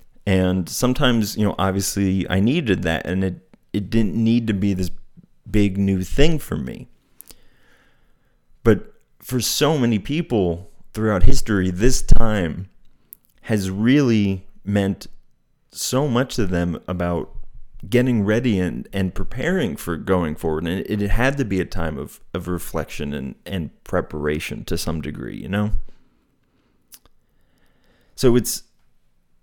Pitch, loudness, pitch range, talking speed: 100 Hz, -22 LUFS, 90-115 Hz, 135 wpm